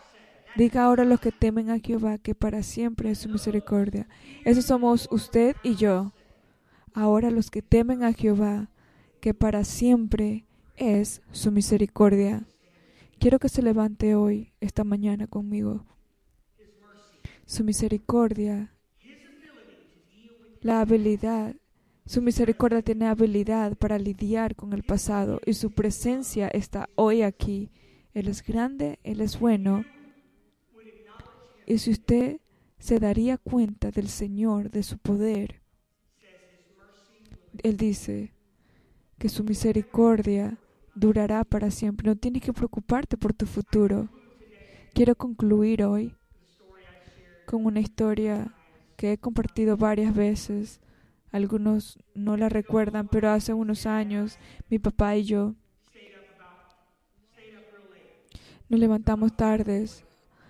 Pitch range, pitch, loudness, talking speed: 205-225 Hz, 215 Hz, -25 LUFS, 115 wpm